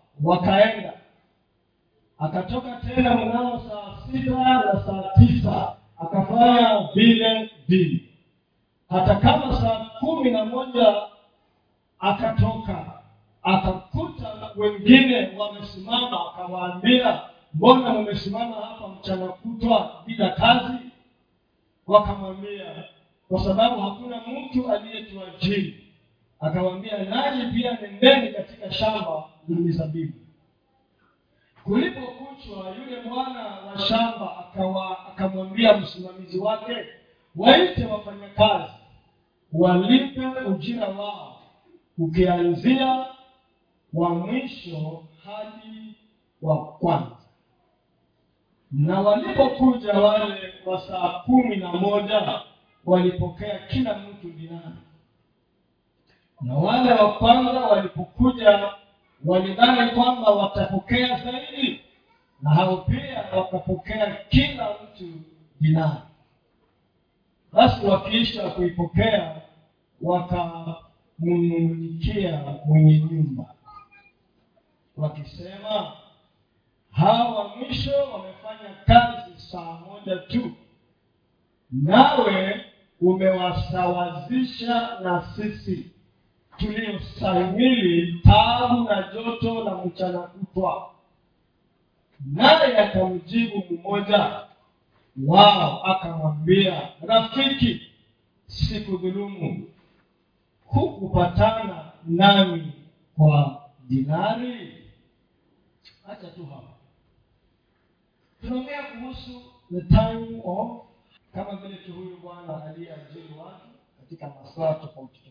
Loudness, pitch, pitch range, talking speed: -21 LUFS, 195 Hz, 170-225 Hz, 75 wpm